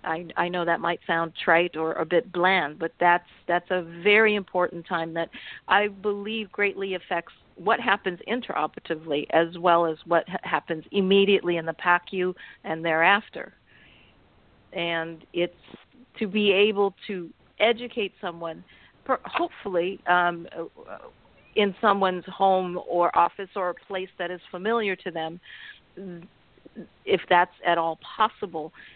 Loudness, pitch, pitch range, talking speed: -25 LUFS, 180 Hz, 170-200 Hz, 135 wpm